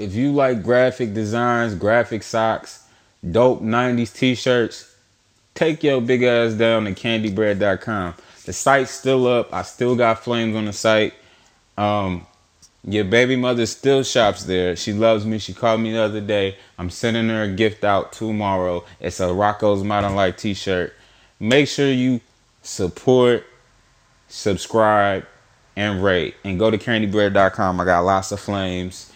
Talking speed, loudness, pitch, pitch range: 150 wpm, -19 LUFS, 110 Hz, 100-120 Hz